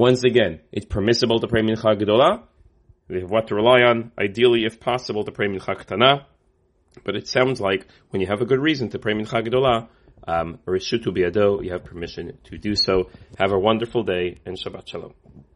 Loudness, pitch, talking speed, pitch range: -21 LUFS, 110 Hz, 200 wpm, 95-120 Hz